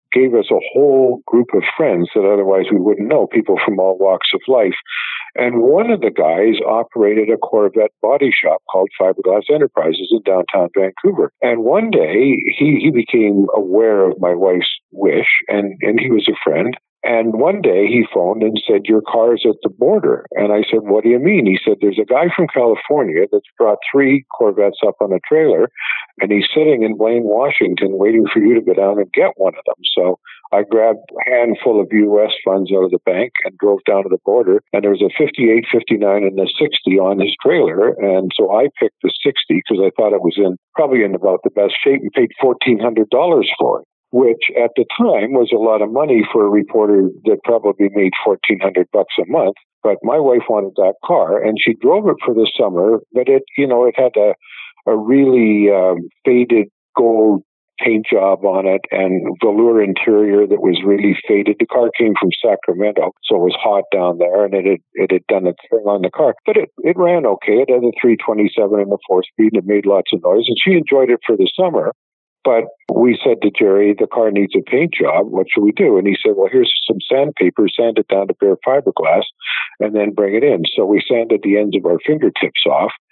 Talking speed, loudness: 220 wpm, -14 LUFS